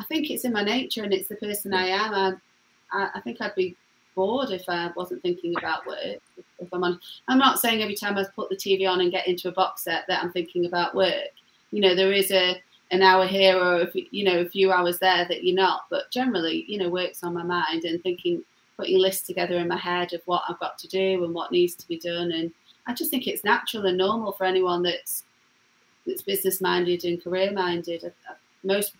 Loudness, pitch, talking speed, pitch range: -25 LUFS, 185 Hz, 240 wpm, 175-205 Hz